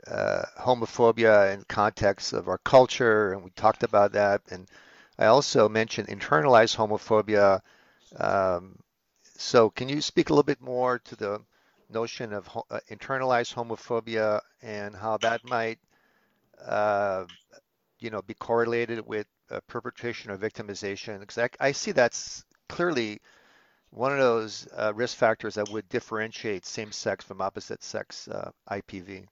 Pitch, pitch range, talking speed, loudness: 110 Hz, 105-120 Hz, 145 wpm, -26 LUFS